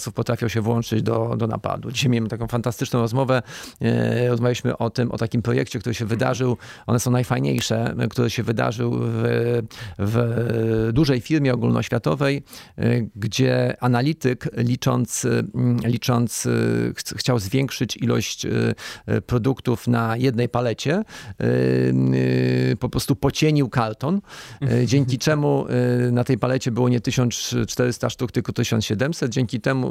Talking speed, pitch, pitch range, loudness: 120 wpm, 120 Hz, 115-130 Hz, -22 LUFS